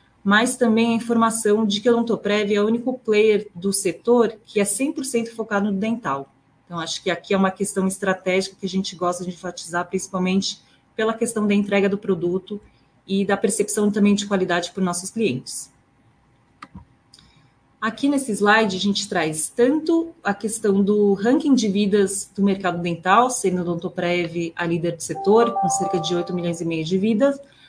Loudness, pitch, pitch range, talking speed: -21 LUFS, 200 Hz, 185-220 Hz, 175 wpm